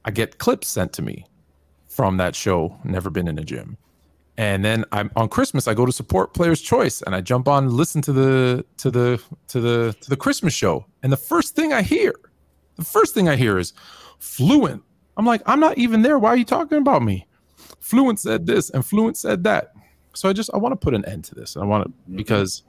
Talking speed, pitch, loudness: 235 wpm, 130 Hz, -20 LUFS